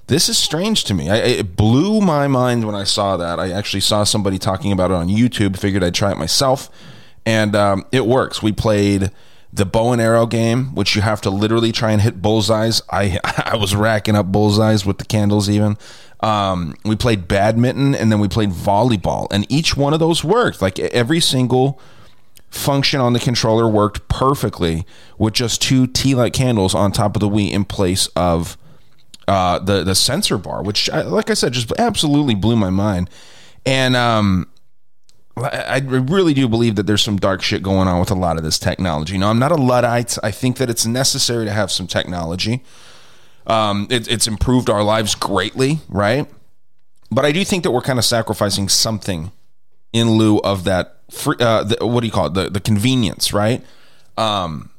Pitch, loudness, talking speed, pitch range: 110 Hz, -16 LUFS, 195 wpm, 100-125 Hz